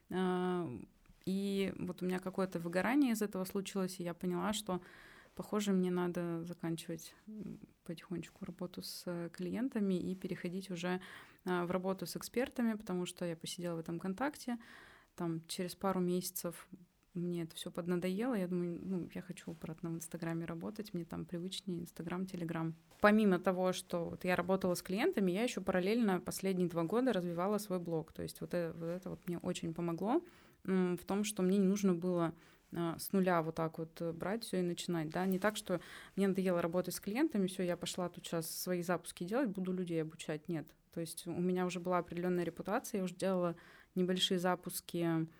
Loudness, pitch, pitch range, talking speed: -38 LUFS, 180 Hz, 170-190 Hz, 175 wpm